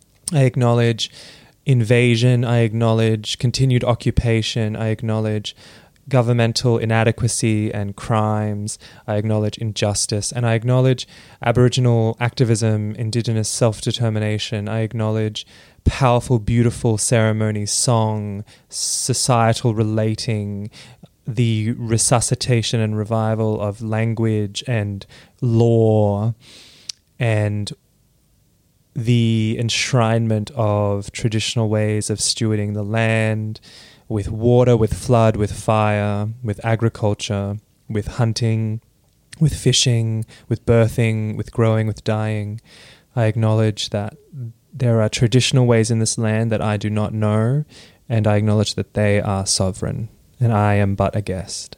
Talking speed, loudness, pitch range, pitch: 110 wpm, -19 LUFS, 105-120 Hz, 110 Hz